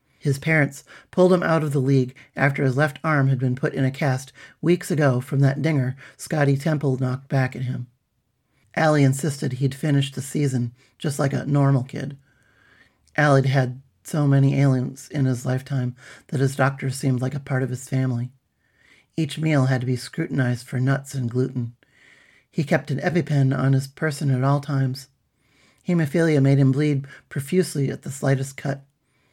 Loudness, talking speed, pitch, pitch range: -22 LUFS, 180 wpm, 135 Hz, 130-145 Hz